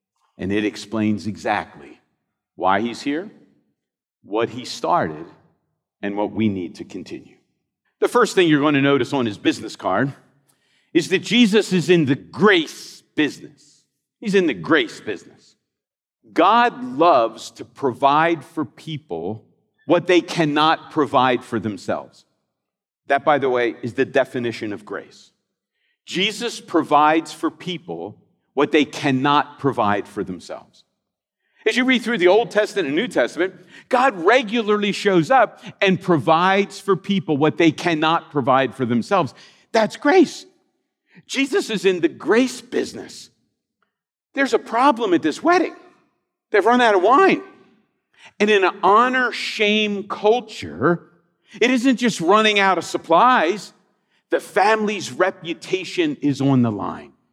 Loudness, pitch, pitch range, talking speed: -19 LUFS, 180 Hz, 145-240 Hz, 140 wpm